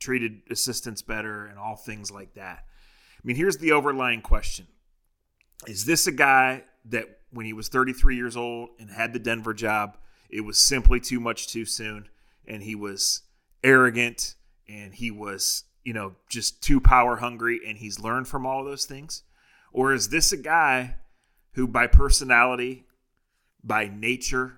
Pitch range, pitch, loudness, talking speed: 110-130 Hz, 120 Hz, -24 LUFS, 165 wpm